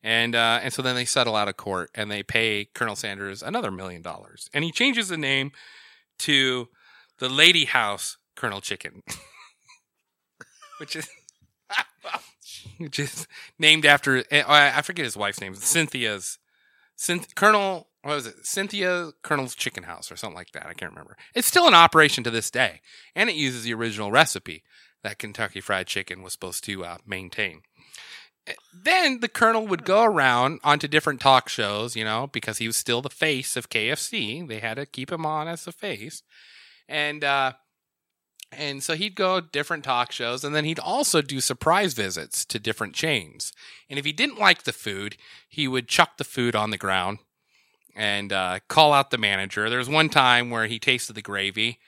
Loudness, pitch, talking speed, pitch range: -22 LUFS, 130 Hz, 185 wpm, 110-155 Hz